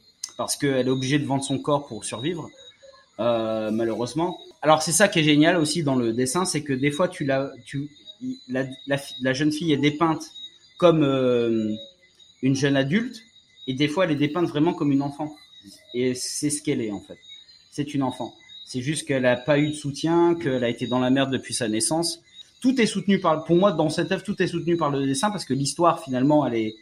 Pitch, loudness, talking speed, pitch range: 145 Hz, -23 LUFS, 225 wpm, 130-170 Hz